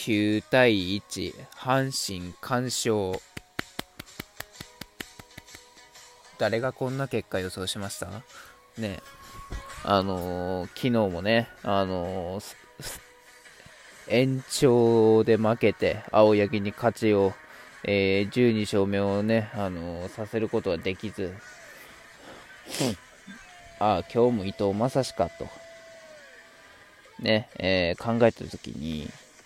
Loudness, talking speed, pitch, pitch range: -26 LUFS, 160 characters per minute, 105 Hz, 95-120 Hz